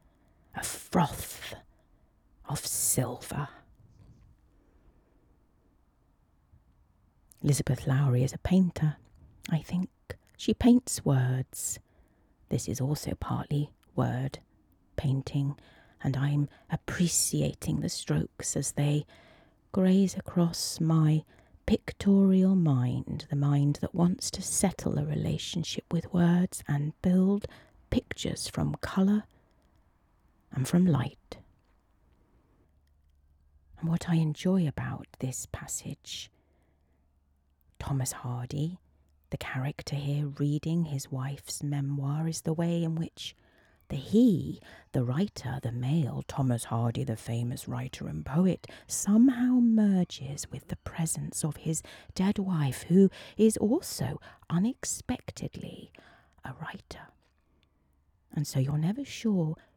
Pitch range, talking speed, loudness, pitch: 105-170 Hz, 105 wpm, -29 LUFS, 140 Hz